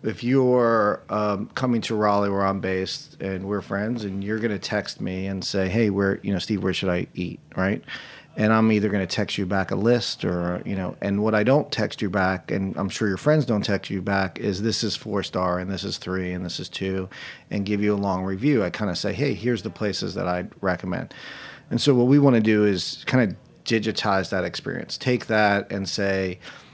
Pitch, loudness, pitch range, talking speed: 100 Hz, -24 LUFS, 95-110 Hz, 240 wpm